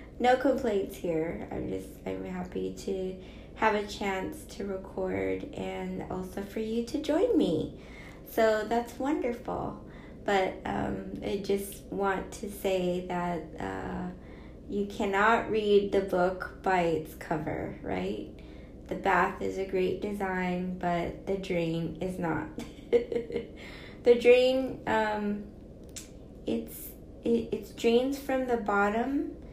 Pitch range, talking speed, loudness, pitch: 170-225 Hz, 125 wpm, -30 LUFS, 195 Hz